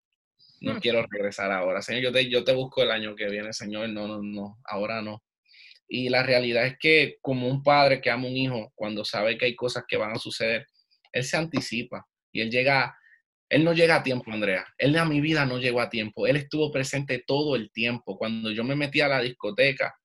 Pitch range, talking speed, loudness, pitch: 110-135 Hz, 225 wpm, -25 LUFS, 125 Hz